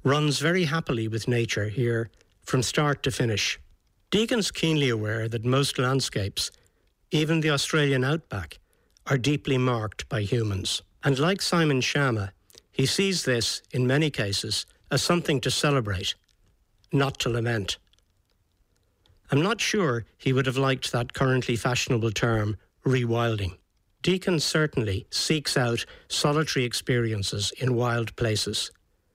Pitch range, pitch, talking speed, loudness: 105-140 Hz, 125 Hz, 130 wpm, -26 LUFS